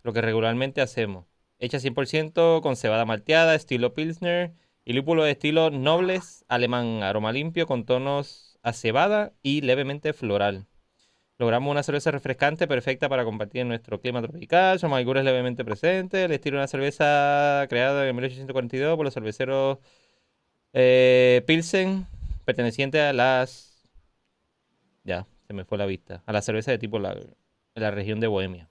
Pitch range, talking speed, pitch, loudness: 115-150 Hz, 150 wpm, 130 Hz, -24 LUFS